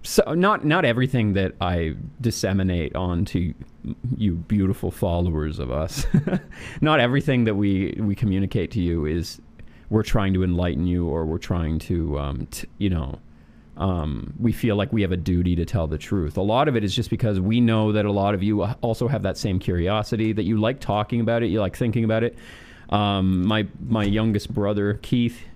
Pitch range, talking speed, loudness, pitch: 85-115 Hz, 195 wpm, -23 LUFS, 100 Hz